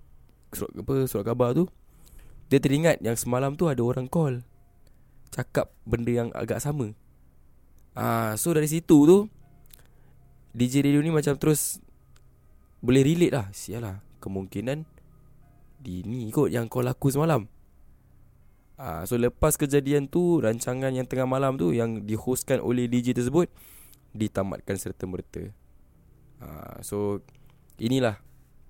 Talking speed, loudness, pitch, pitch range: 130 wpm, -26 LUFS, 120 Hz, 100-140 Hz